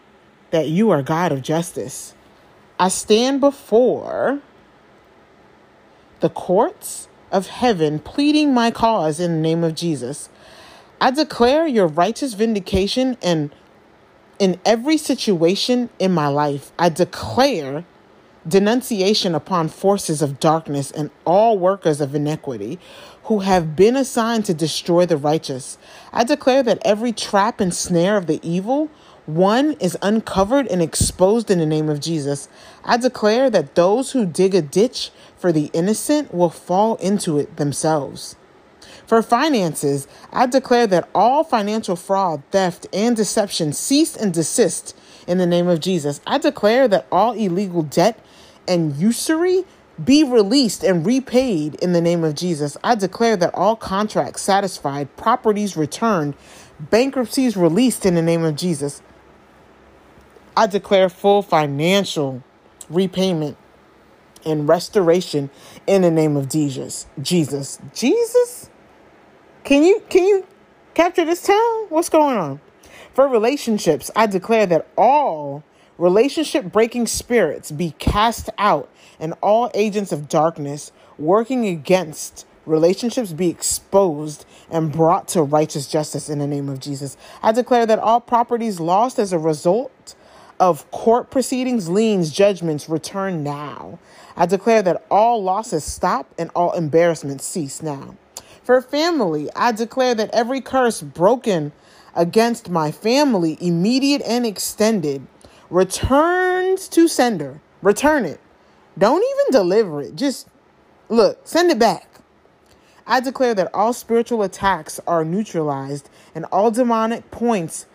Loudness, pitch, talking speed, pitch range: -18 LUFS, 190 Hz, 135 wpm, 160-235 Hz